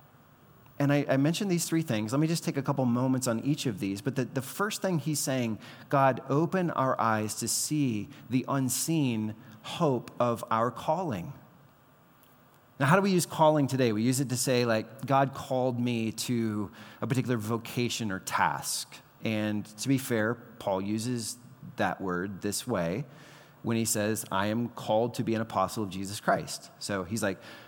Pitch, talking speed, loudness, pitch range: 125 Hz, 185 wpm, -29 LUFS, 110-140 Hz